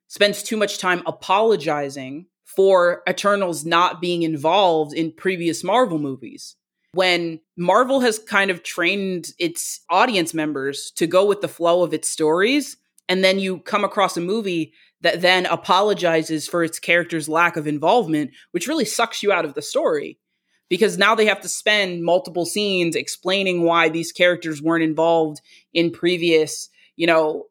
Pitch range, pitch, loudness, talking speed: 165-200 Hz, 175 Hz, -19 LUFS, 160 wpm